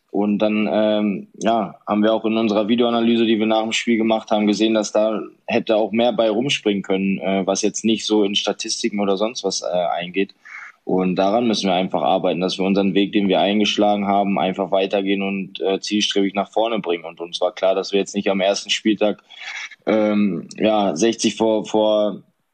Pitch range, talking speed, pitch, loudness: 95-110 Hz, 200 wpm, 105 Hz, -19 LUFS